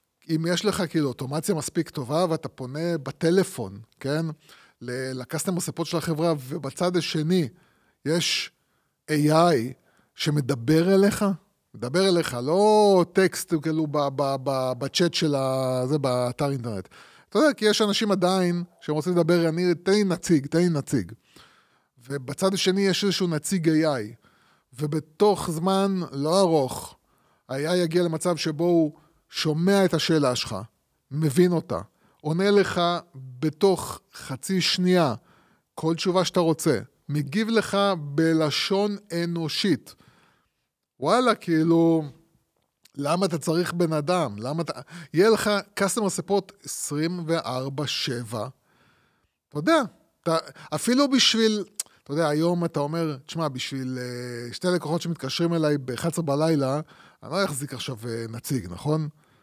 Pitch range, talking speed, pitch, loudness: 140-180 Hz, 125 wpm, 165 Hz, -24 LUFS